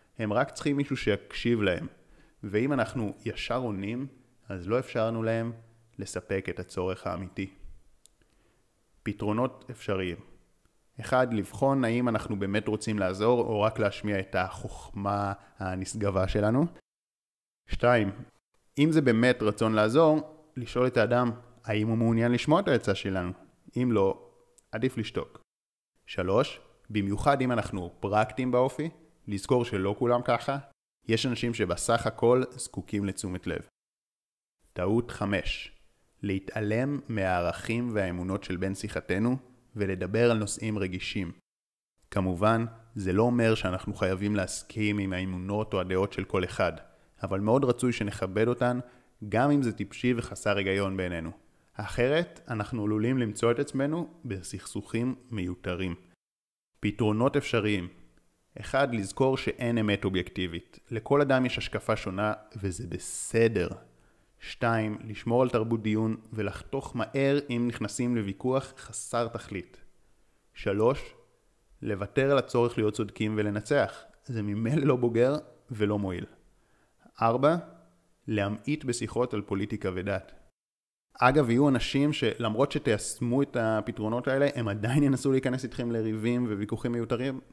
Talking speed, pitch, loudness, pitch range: 120 wpm, 110 Hz, -29 LUFS, 100-125 Hz